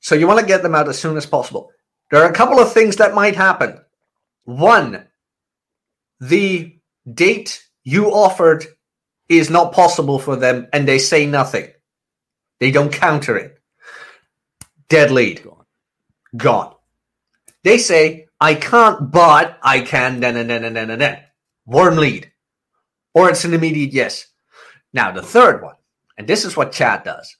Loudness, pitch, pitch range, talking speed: -14 LUFS, 160 Hz, 140-180 Hz, 155 wpm